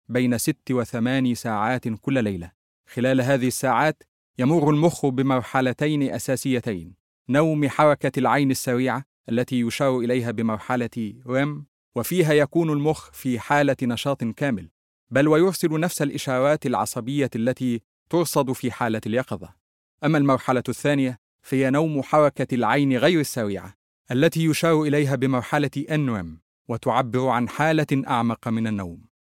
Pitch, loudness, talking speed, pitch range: 130 Hz, -23 LUFS, 125 wpm, 120-145 Hz